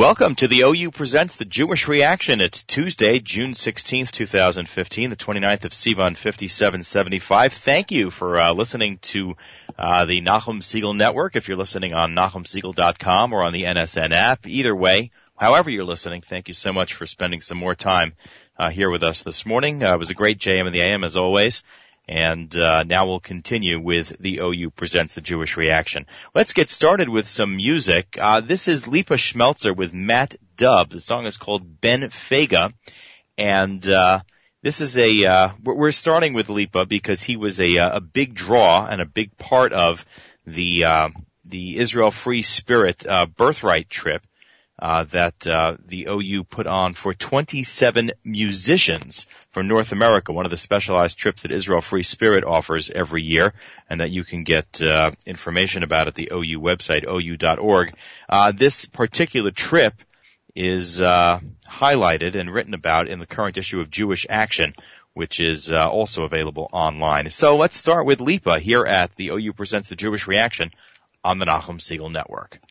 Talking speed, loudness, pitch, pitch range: 175 wpm, -19 LUFS, 95 Hz, 85-110 Hz